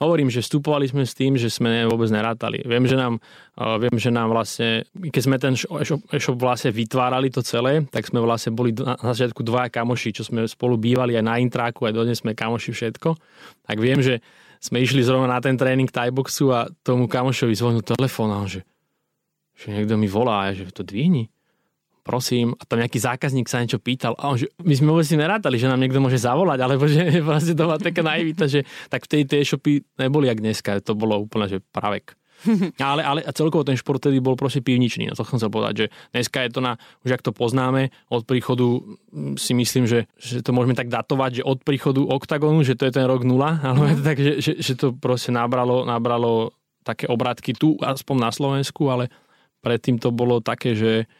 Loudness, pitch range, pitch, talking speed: -21 LUFS, 115-140 Hz, 125 Hz, 210 wpm